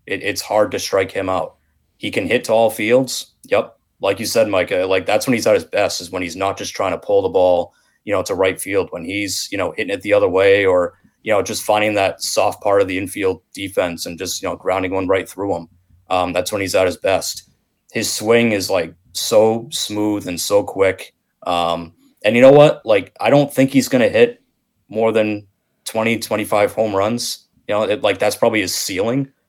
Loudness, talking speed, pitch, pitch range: -17 LUFS, 230 wpm, 110 Hz, 95-160 Hz